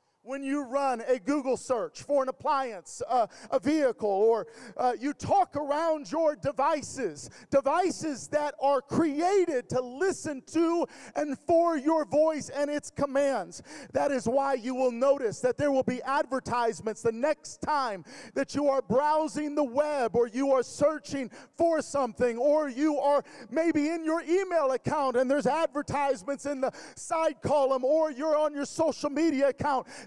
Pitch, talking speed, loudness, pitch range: 285 Hz, 160 wpm, -28 LUFS, 265-305 Hz